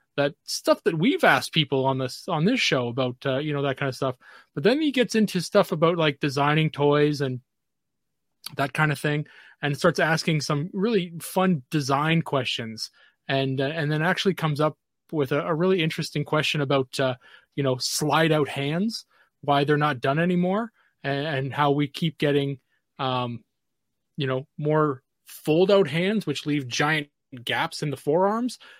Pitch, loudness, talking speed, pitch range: 150 Hz, -24 LUFS, 180 wpm, 140-170 Hz